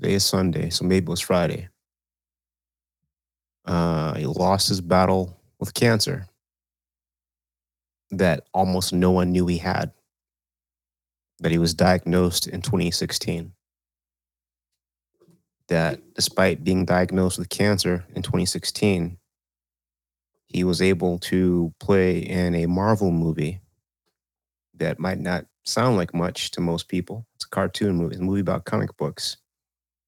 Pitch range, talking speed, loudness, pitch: 60-95 Hz, 130 wpm, -23 LUFS, 85 Hz